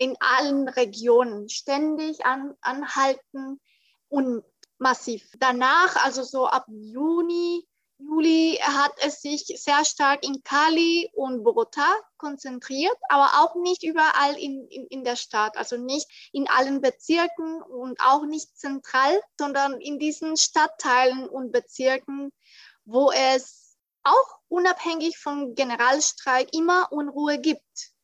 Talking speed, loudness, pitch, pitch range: 120 wpm, -23 LUFS, 280 Hz, 260-320 Hz